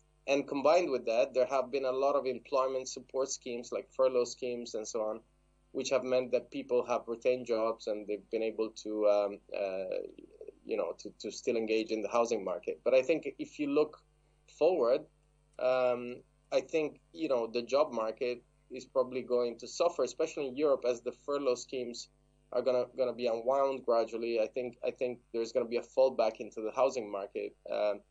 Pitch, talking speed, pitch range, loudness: 125 Hz, 195 wpm, 115-145 Hz, -33 LUFS